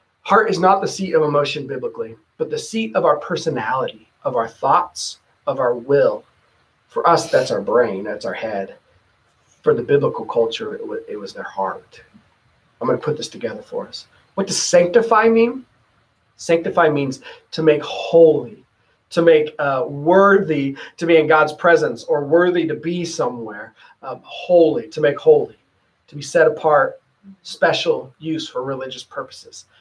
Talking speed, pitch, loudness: 165 wpm, 175 Hz, -18 LUFS